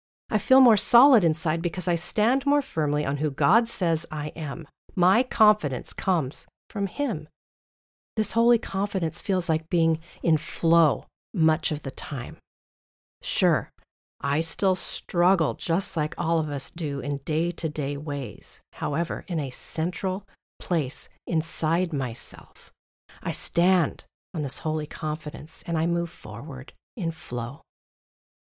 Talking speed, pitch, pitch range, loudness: 140 wpm, 165 Hz, 150-185 Hz, -25 LUFS